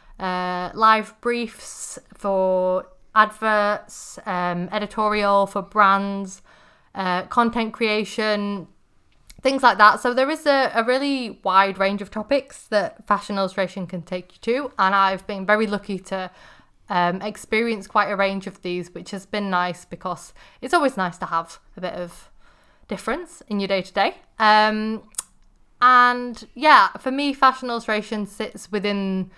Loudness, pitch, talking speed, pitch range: -21 LUFS, 210 Hz, 145 wpm, 190-230 Hz